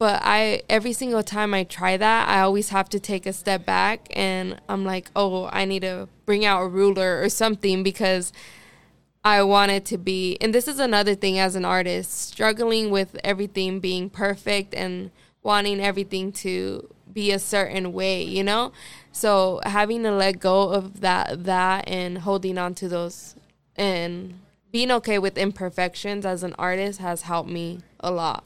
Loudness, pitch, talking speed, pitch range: -23 LUFS, 195 Hz, 175 wpm, 185-205 Hz